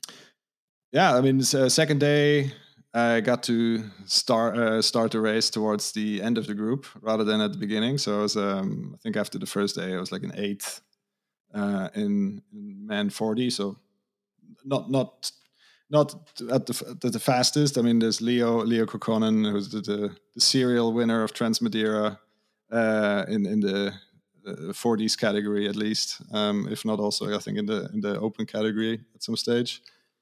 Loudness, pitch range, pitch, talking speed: -25 LUFS, 105-130 Hz, 115 Hz, 185 wpm